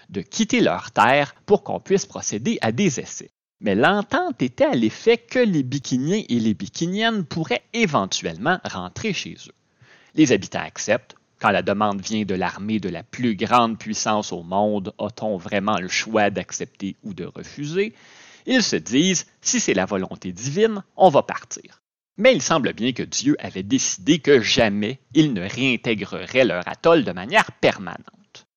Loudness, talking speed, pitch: -21 LUFS, 170 wpm, 125 Hz